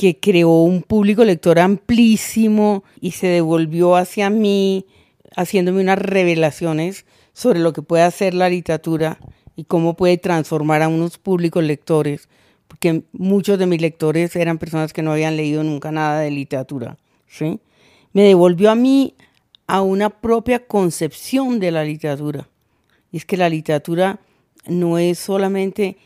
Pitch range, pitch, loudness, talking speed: 160-195 Hz, 175 Hz, -17 LUFS, 145 wpm